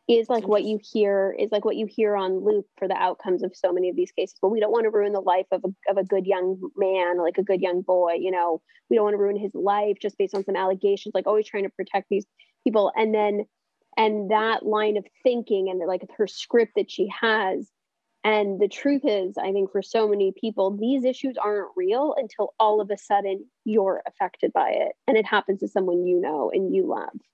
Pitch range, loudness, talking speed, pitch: 190-220 Hz, -24 LUFS, 245 wpm, 205 Hz